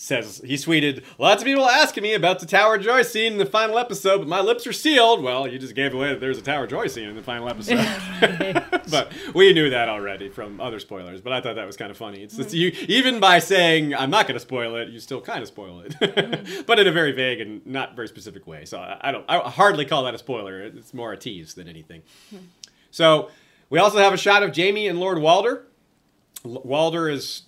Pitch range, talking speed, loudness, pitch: 125-205 Hz, 245 wpm, -20 LUFS, 165 Hz